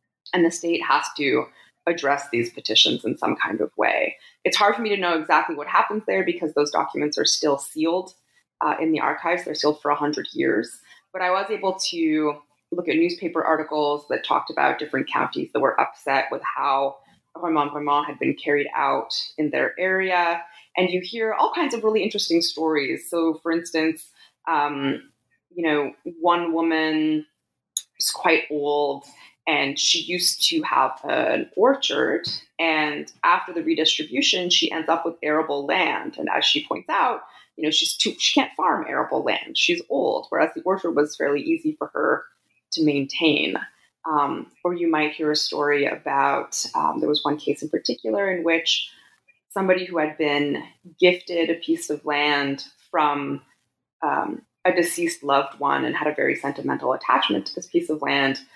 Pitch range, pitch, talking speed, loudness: 145-180 Hz, 160 Hz, 175 wpm, -22 LUFS